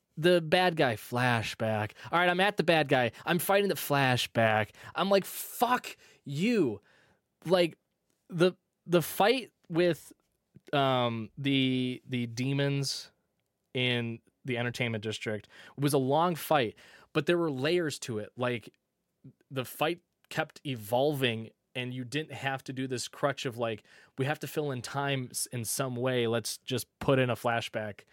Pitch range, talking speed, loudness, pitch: 120-165 Hz, 155 wpm, -30 LUFS, 135 Hz